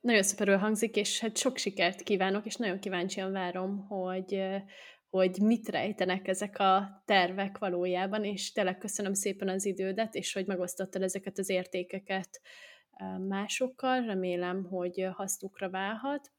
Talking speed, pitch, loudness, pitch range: 135 wpm, 195 Hz, -32 LUFS, 190-205 Hz